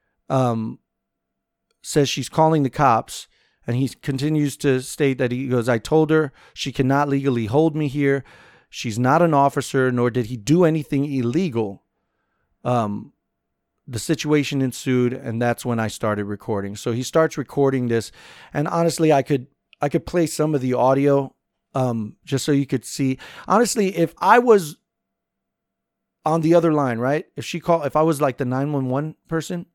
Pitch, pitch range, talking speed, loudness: 140 Hz, 125-155 Hz, 170 wpm, -21 LUFS